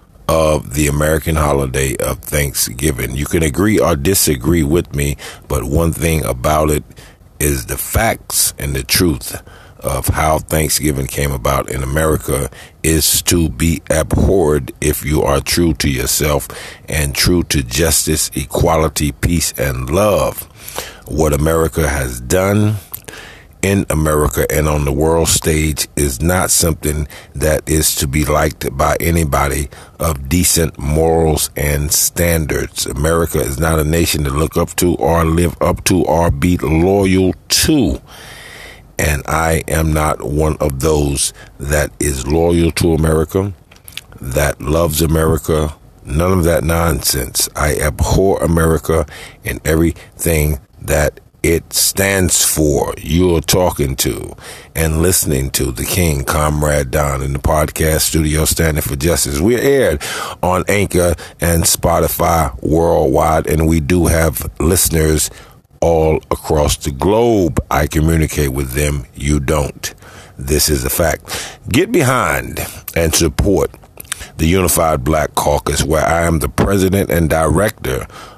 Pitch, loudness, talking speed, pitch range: 80 Hz, -15 LUFS, 135 wpm, 75-85 Hz